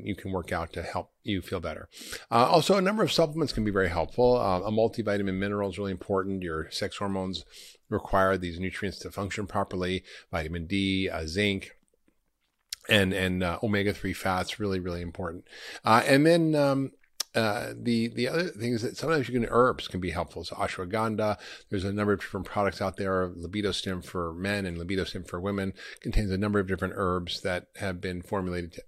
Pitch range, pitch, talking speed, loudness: 90-110 Hz, 95 Hz, 195 wpm, -28 LUFS